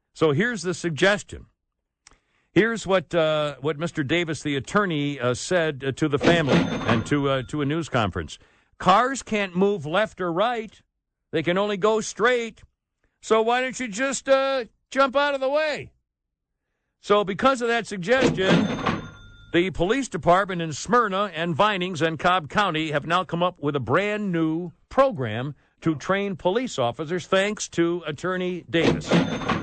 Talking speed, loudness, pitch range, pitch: 160 wpm, -23 LUFS, 150-210 Hz, 180 Hz